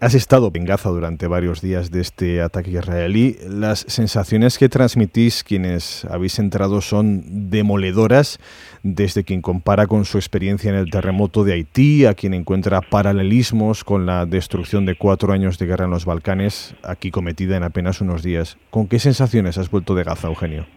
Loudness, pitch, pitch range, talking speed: -18 LUFS, 95 Hz, 90-105 Hz, 175 wpm